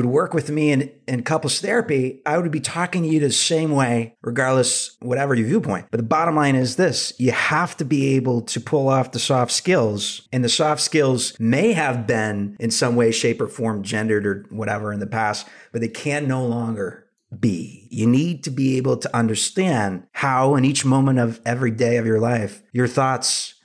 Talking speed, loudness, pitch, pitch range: 210 wpm, -20 LUFS, 130 Hz, 115-145 Hz